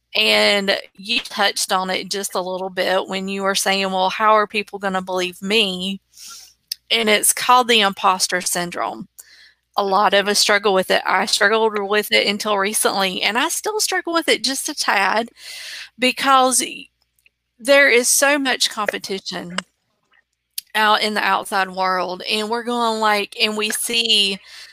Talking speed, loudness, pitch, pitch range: 165 wpm, -17 LUFS, 210 Hz, 195-240 Hz